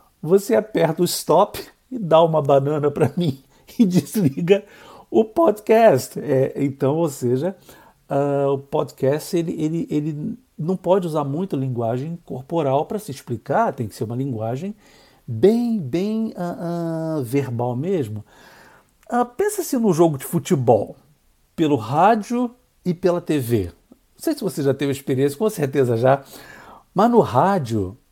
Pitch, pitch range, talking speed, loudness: 155 Hz, 135-190 Hz, 145 wpm, -20 LUFS